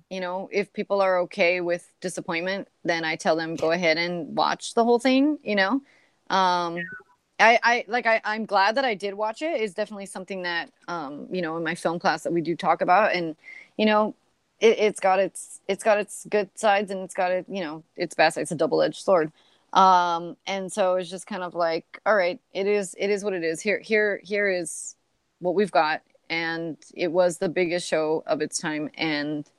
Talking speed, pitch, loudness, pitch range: 220 wpm, 185 Hz, -24 LUFS, 170-210 Hz